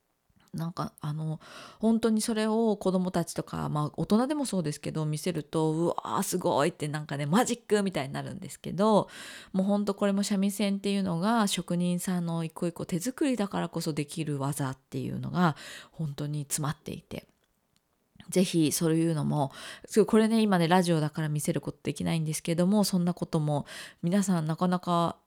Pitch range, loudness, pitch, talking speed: 155-200 Hz, -29 LUFS, 175 Hz, 380 characters per minute